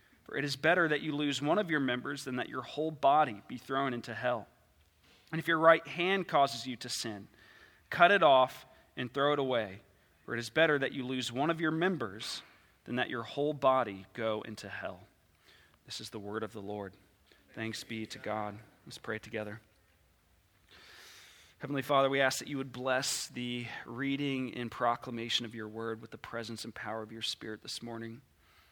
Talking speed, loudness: 195 wpm, -33 LUFS